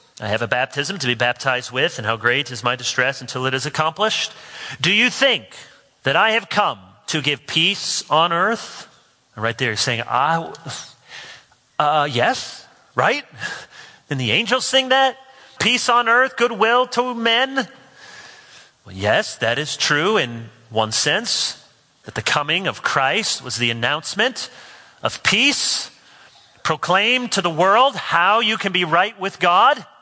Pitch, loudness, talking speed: 195 Hz, -18 LUFS, 155 wpm